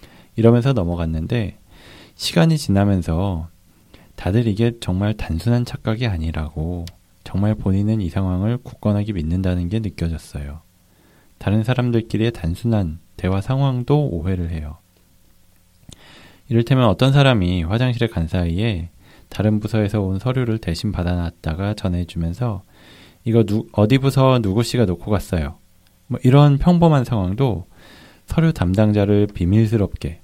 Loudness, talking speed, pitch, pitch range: -19 LUFS, 300 characters per minute, 100 Hz, 90-115 Hz